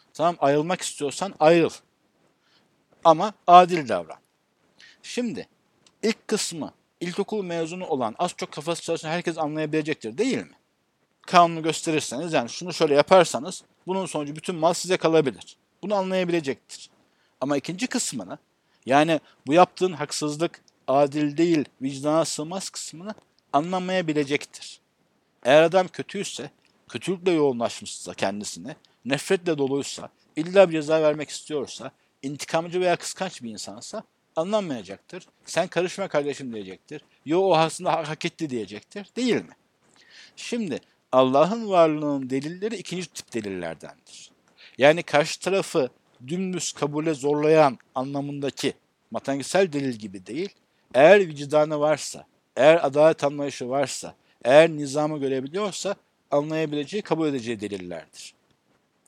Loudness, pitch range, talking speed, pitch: -24 LUFS, 145-185 Hz, 115 wpm, 160 Hz